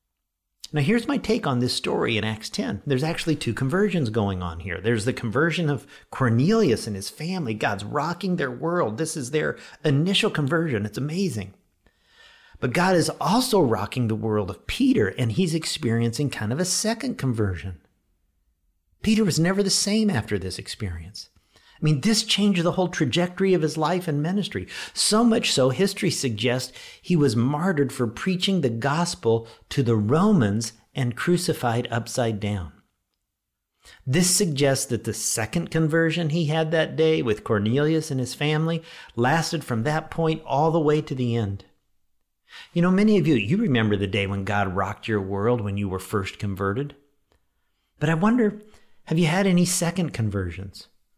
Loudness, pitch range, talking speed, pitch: -23 LUFS, 105-175 Hz, 170 wpm, 140 Hz